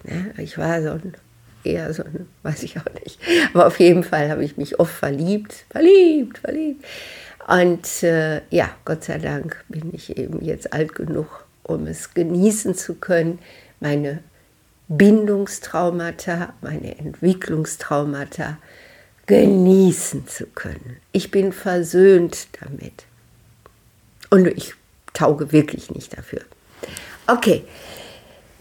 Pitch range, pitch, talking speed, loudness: 155-195 Hz, 175 Hz, 120 wpm, -19 LUFS